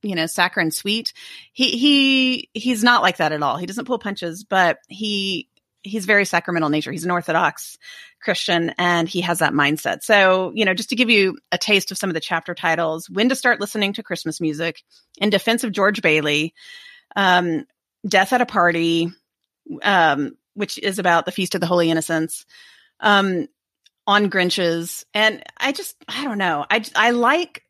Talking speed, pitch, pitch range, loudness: 185 wpm, 190 Hz, 170-225 Hz, -19 LUFS